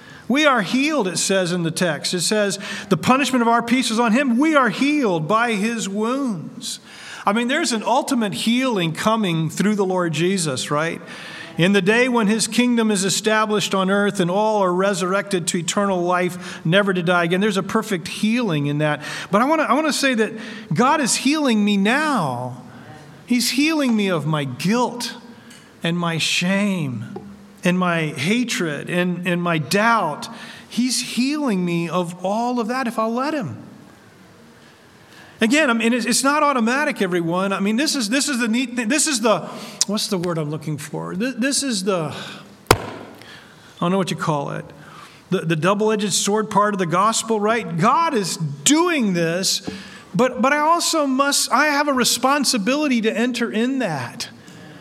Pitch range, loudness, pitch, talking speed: 180-245 Hz, -19 LUFS, 215 Hz, 180 wpm